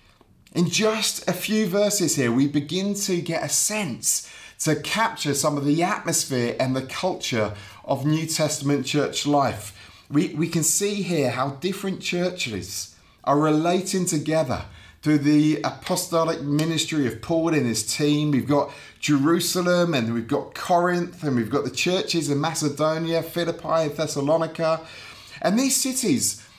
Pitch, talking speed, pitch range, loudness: 155 Hz, 150 wpm, 140-175 Hz, -23 LUFS